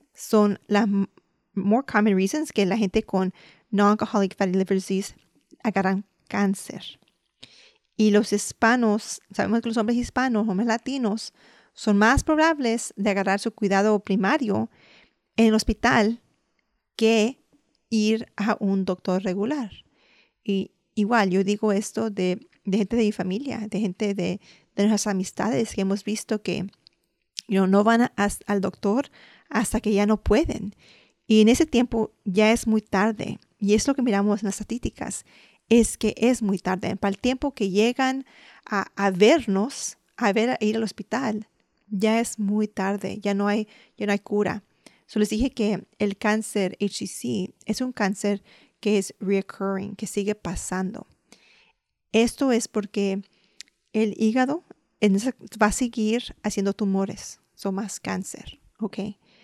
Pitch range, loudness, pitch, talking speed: 200-225 Hz, -24 LUFS, 210 Hz, 155 wpm